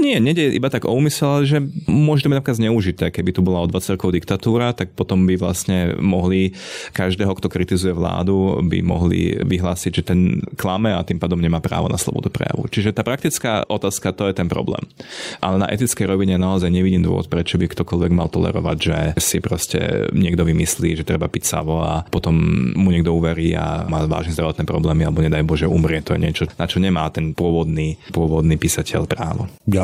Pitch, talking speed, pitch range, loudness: 90 Hz, 190 wpm, 85-100 Hz, -19 LUFS